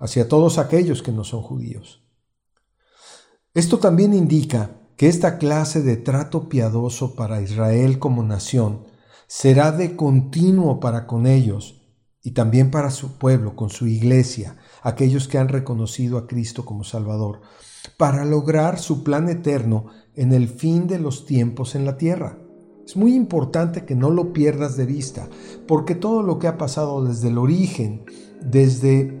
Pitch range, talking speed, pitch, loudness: 120-155 Hz, 155 wpm, 135 Hz, -19 LUFS